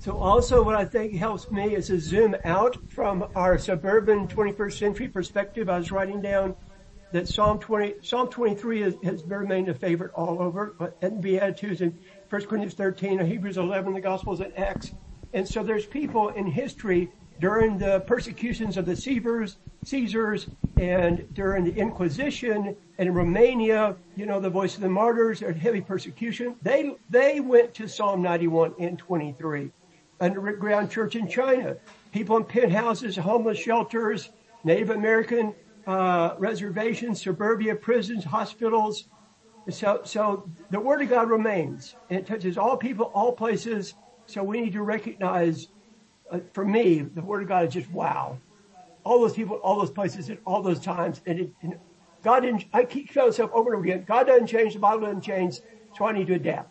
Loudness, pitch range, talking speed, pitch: -25 LUFS, 185-225 Hz, 175 wpm, 205 Hz